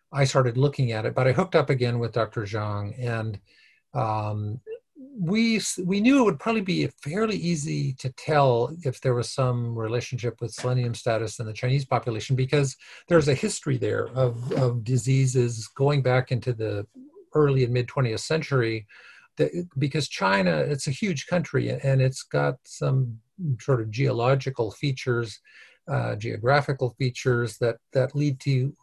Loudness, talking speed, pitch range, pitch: -25 LUFS, 160 wpm, 120-145 Hz, 130 Hz